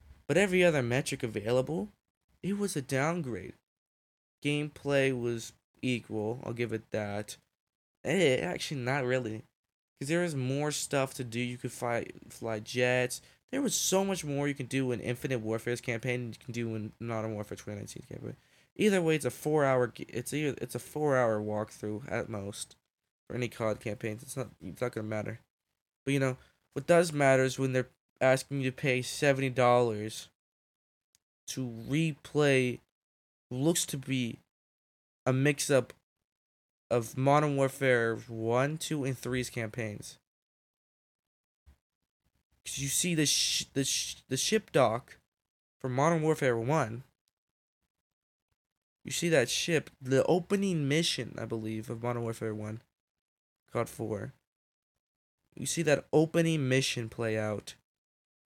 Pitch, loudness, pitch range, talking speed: 125 Hz, -31 LUFS, 115-140 Hz, 150 wpm